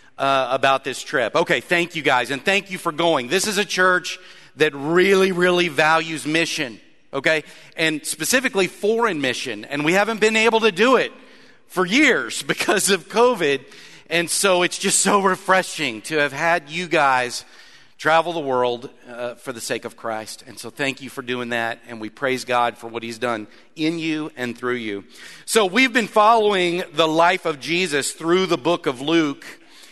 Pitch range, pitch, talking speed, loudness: 135-185 Hz, 160 Hz, 185 wpm, -19 LUFS